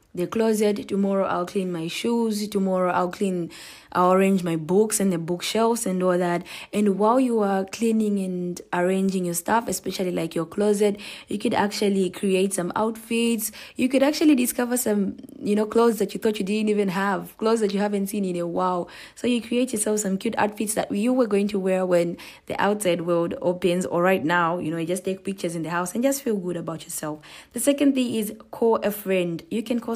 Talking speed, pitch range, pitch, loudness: 215 wpm, 180-220 Hz, 200 Hz, -23 LUFS